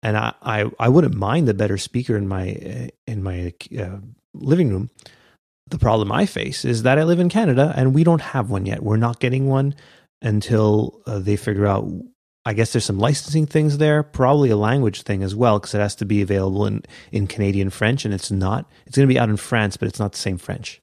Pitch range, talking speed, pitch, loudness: 100-135 Hz, 230 wpm, 110 Hz, -20 LUFS